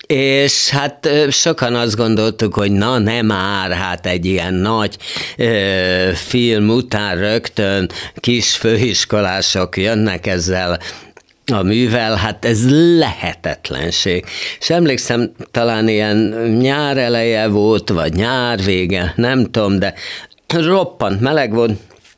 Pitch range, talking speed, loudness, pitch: 95-120 Hz, 115 wpm, -15 LUFS, 110 Hz